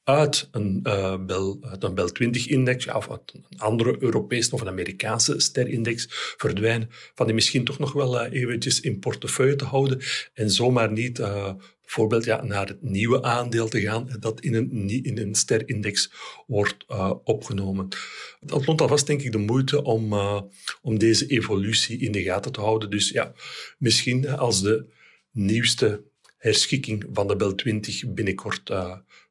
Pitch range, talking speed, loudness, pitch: 105-130 Hz, 160 wpm, -24 LUFS, 115 Hz